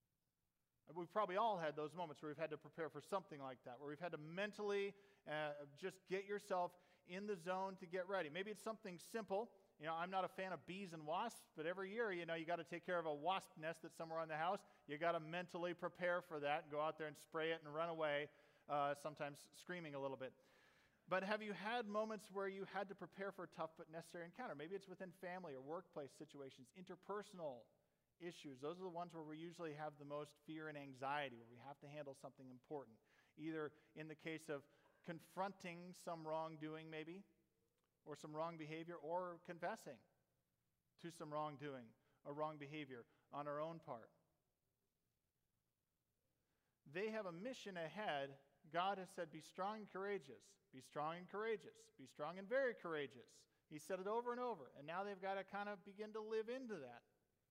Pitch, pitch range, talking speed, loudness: 170 Hz, 150-190 Hz, 205 wpm, -49 LUFS